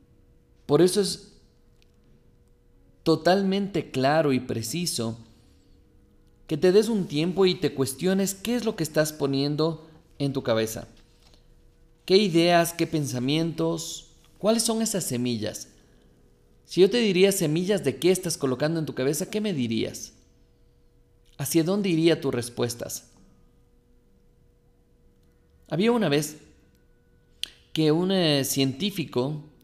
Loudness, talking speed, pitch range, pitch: -25 LUFS, 120 wpm, 125-180 Hz, 155 Hz